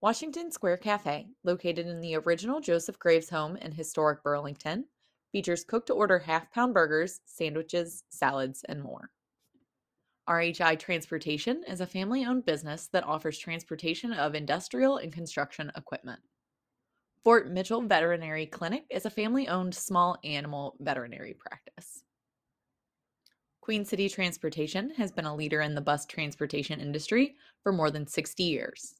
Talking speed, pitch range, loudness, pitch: 140 wpm, 155-205 Hz, -30 LUFS, 170 Hz